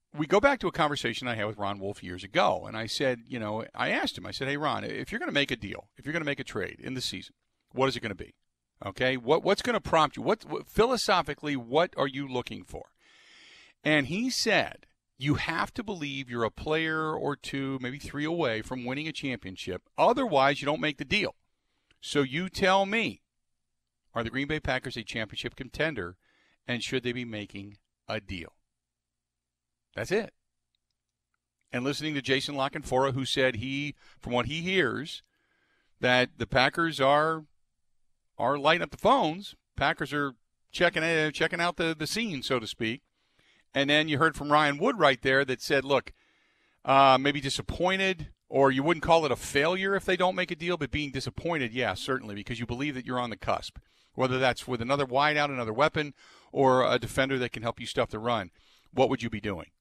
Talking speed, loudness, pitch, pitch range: 205 wpm, -28 LUFS, 135 Hz, 120-155 Hz